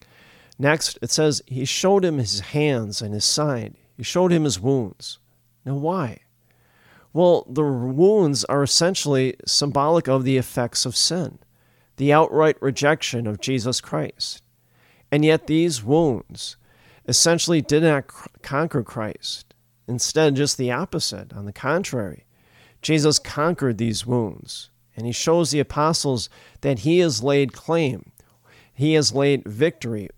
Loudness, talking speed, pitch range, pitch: -21 LUFS, 135 wpm, 120-155 Hz, 135 Hz